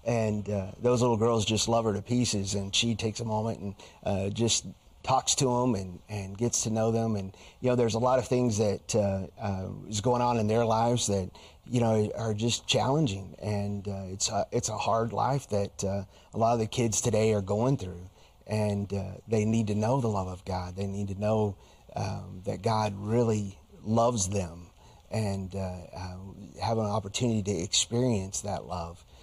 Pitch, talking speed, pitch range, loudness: 105 Hz, 205 wpm, 95-115 Hz, -29 LUFS